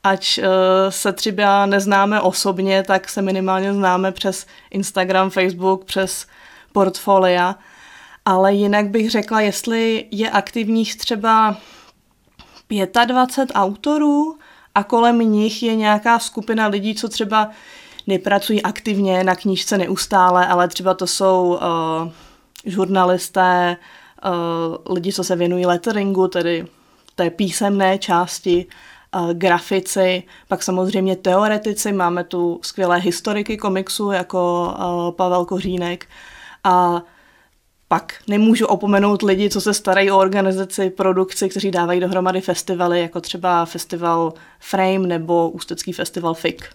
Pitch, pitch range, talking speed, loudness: 190 Hz, 180-205 Hz, 115 wpm, -18 LUFS